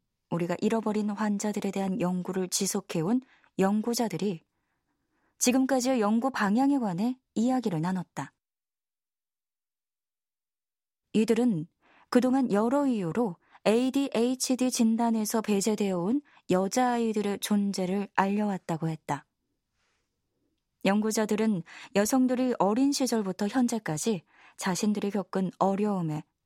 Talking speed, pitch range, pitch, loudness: 255 characters per minute, 190-240 Hz, 210 Hz, -28 LUFS